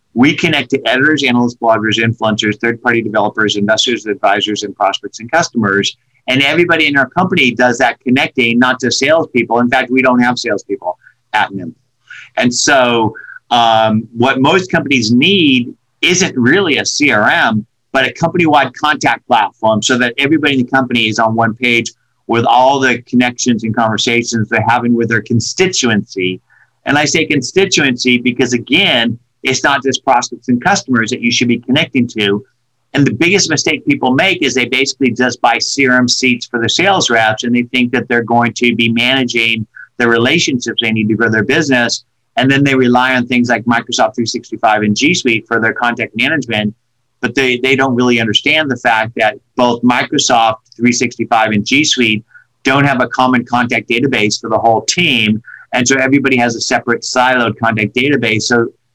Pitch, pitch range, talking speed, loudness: 120 Hz, 115-130 Hz, 175 wpm, -12 LUFS